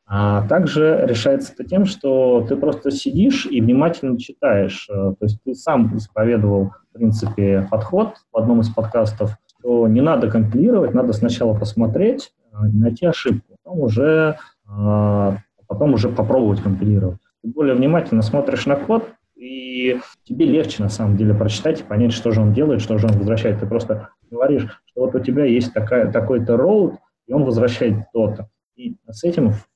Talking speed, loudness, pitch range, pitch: 165 wpm, -18 LUFS, 105-140 Hz, 115 Hz